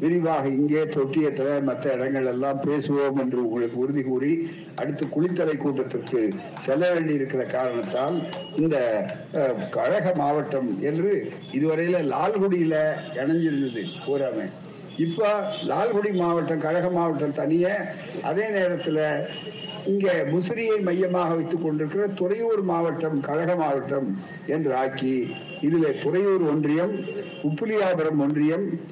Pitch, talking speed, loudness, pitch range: 160 Hz, 100 wpm, -25 LUFS, 145-180 Hz